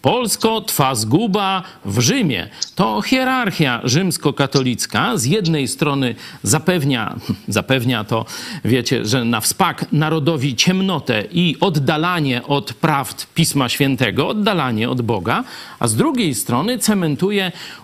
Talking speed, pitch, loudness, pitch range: 115 wpm, 150 Hz, -17 LUFS, 130-180 Hz